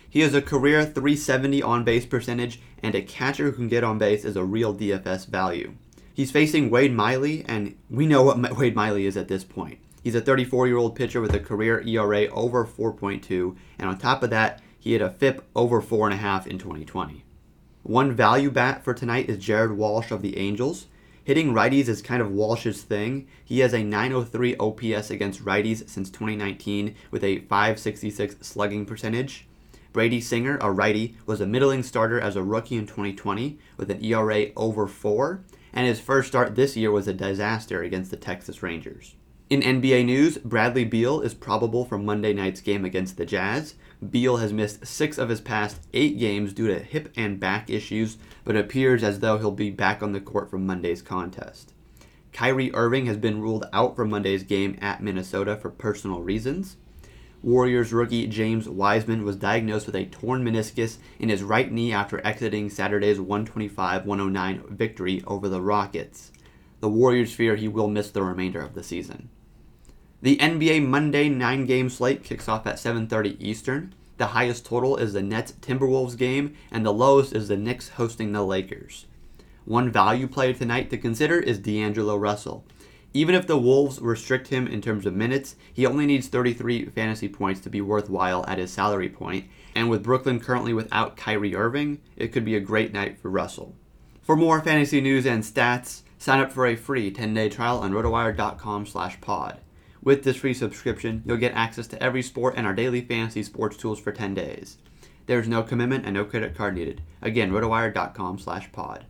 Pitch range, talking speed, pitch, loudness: 100-125 Hz, 185 wpm, 110 Hz, -24 LUFS